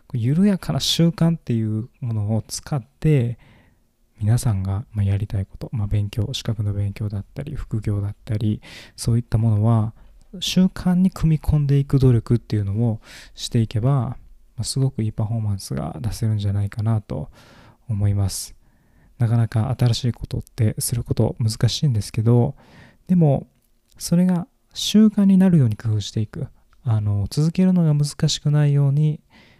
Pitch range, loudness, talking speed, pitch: 110-140 Hz, -21 LUFS, 325 characters per minute, 115 Hz